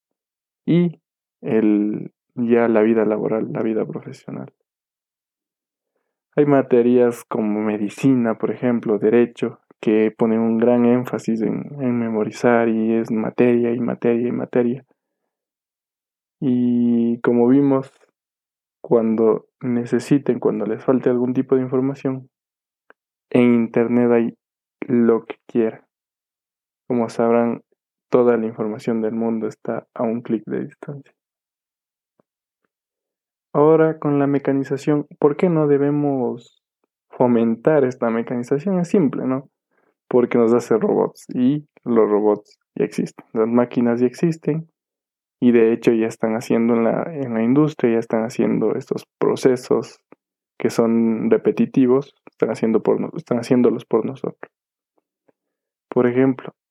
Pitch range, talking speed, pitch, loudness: 115-135 Hz, 125 wpm, 120 Hz, -19 LUFS